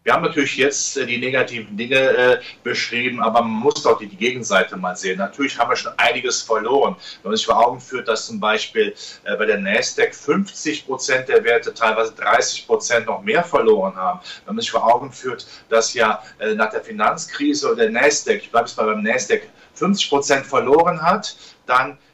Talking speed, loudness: 190 wpm, -19 LUFS